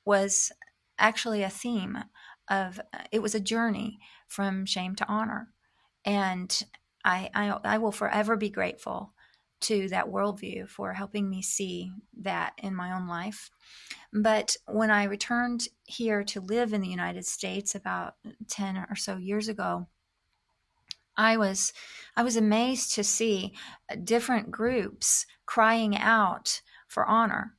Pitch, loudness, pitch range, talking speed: 210 Hz, -28 LUFS, 195-225 Hz, 135 wpm